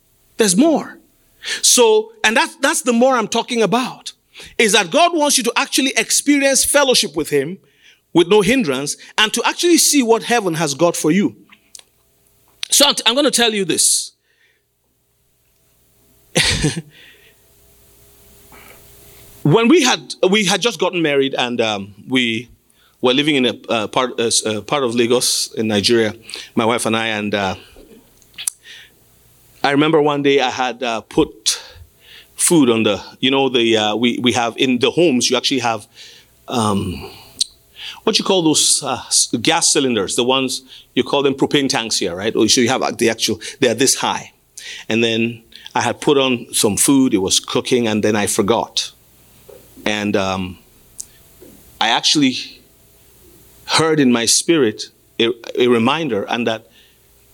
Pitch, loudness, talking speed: 140 Hz, -16 LUFS, 155 wpm